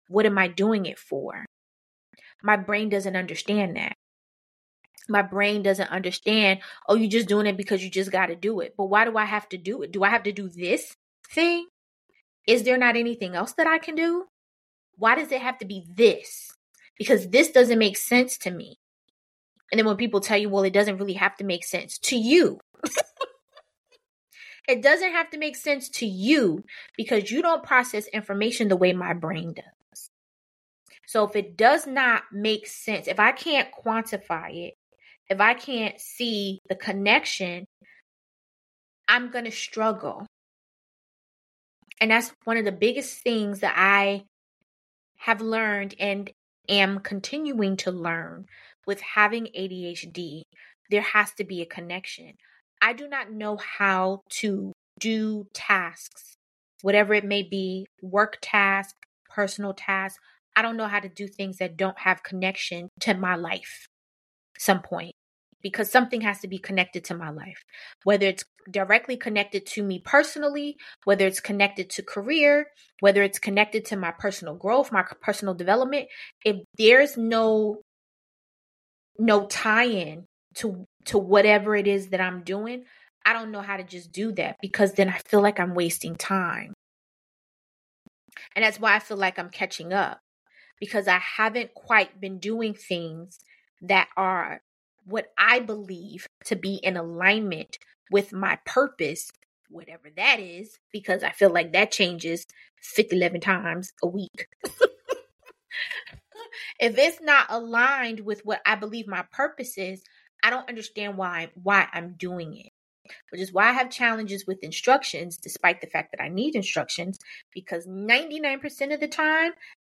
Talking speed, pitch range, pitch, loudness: 160 wpm, 190-230 Hz, 205 Hz, -24 LUFS